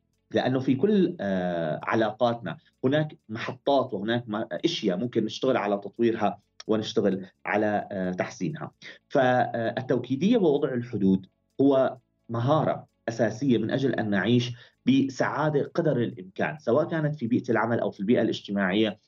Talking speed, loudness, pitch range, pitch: 115 wpm, -26 LUFS, 105-140 Hz, 115 Hz